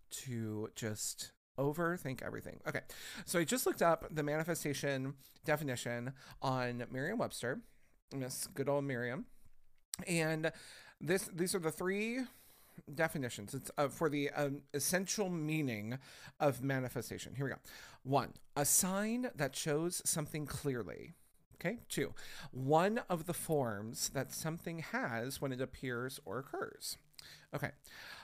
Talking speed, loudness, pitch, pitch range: 130 wpm, -38 LUFS, 145 Hz, 130-165 Hz